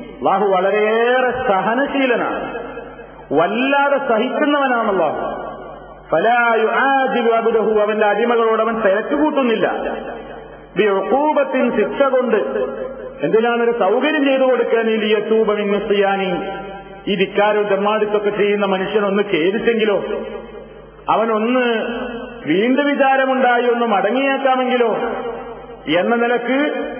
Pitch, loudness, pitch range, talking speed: 235 Hz, -17 LUFS, 210-260 Hz, 80 wpm